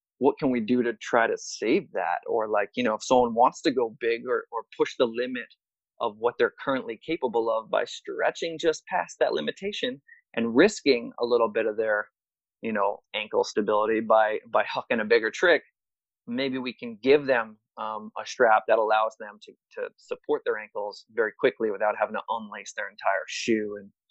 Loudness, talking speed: -26 LUFS, 195 wpm